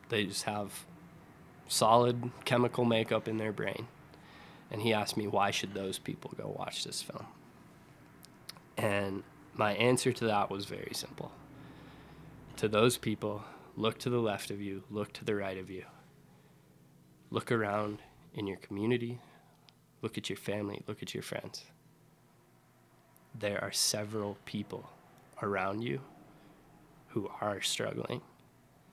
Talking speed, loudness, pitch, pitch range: 135 wpm, -34 LUFS, 110 Hz, 100-120 Hz